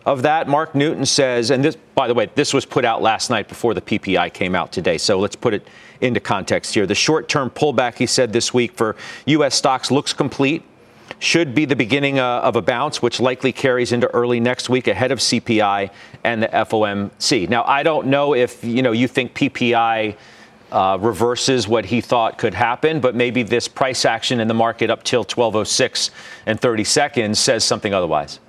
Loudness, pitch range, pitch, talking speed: -18 LUFS, 115-140 Hz, 125 Hz, 200 wpm